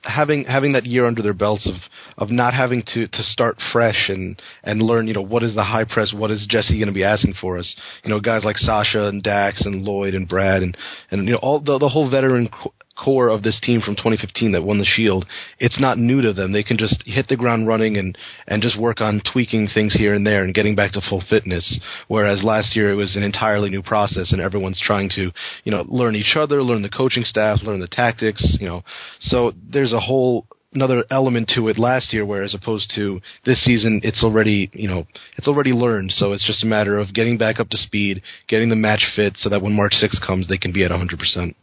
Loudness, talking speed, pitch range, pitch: -18 LUFS, 245 wpm, 100-120 Hz, 110 Hz